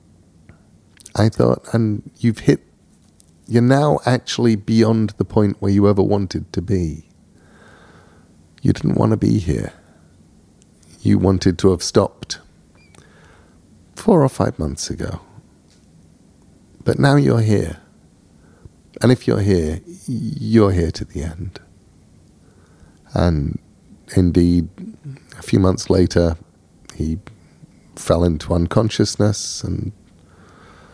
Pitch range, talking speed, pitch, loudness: 85-110 Hz, 110 wpm, 95 Hz, -18 LUFS